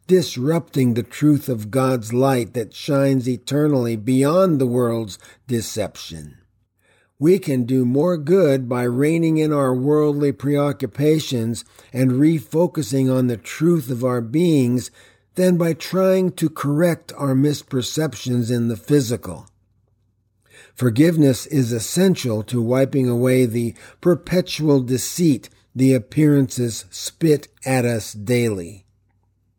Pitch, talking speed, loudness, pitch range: 130 Hz, 115 wpm, -19 LUFS, 115-150 Hz